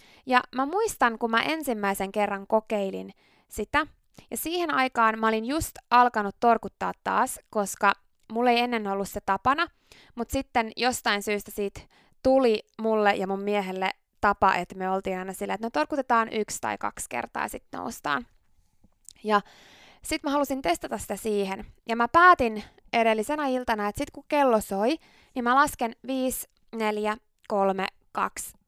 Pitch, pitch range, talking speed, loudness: 220 Hz, 200-255 Hz, 155 wpm, -26 LUFS